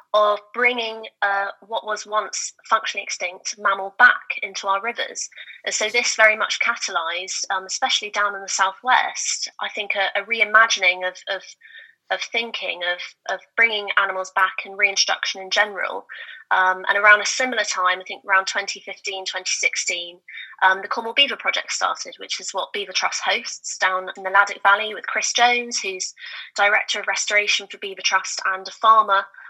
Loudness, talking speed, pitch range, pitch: -20 LUFS, 170 wpm, 190-220 Hz, 200 Hz